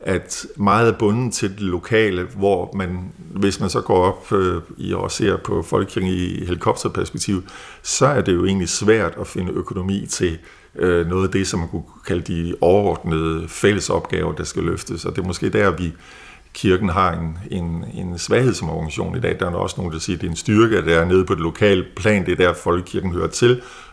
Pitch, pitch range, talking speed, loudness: 90 Hz, 85-100 Hz, 215 wpm, -20 LUFS